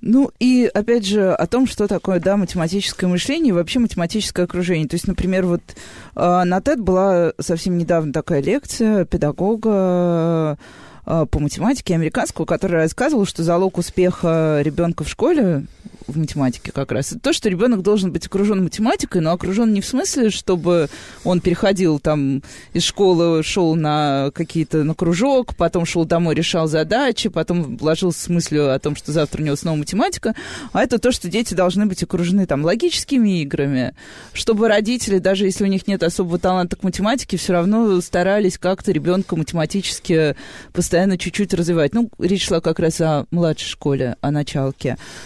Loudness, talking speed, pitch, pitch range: -18 LUFS, 165 wpm, 180 Hz, 160-200 Hz